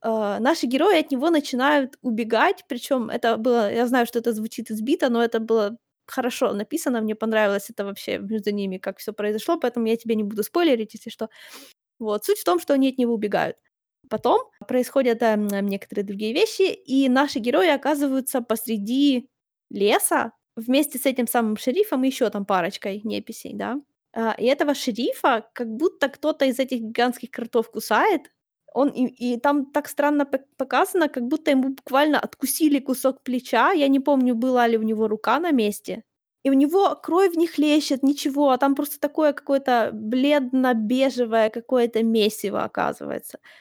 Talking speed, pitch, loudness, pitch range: 170 wpm, 255 Hz, -22 LUFS, 225-285 Hz